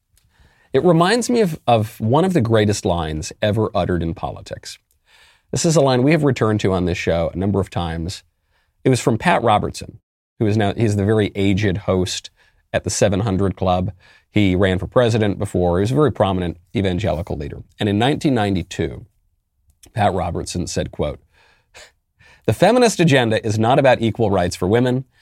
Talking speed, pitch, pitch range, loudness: 180 wpm, 100 Hz, 90-115 Hz, -18 LUFS